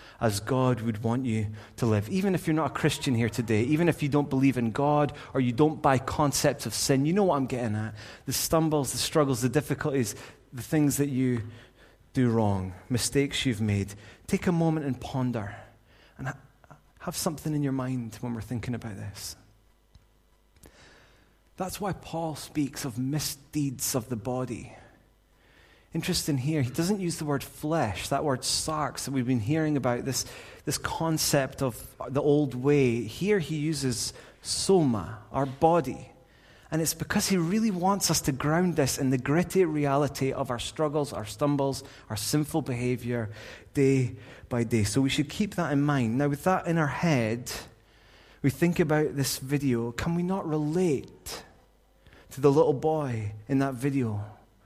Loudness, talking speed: -28 LUFS, 175 wpm